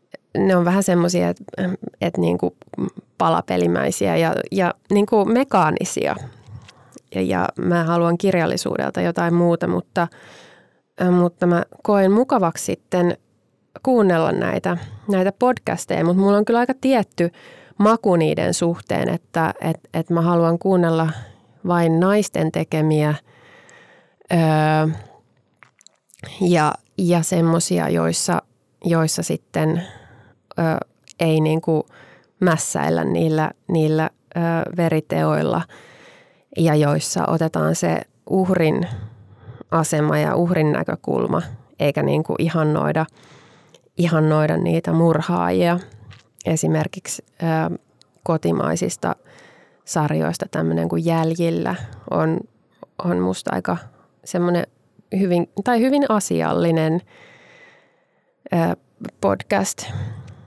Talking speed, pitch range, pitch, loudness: 95 wpm, 120-175 Hz, 165 Hz, -20 LUFS